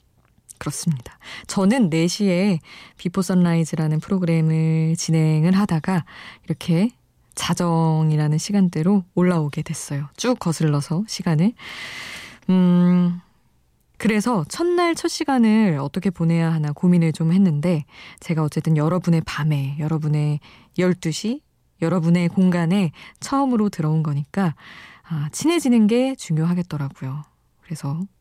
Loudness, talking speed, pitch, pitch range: -21 LUFS, 275 characters per minute, 170 Hz, 155-195 Hz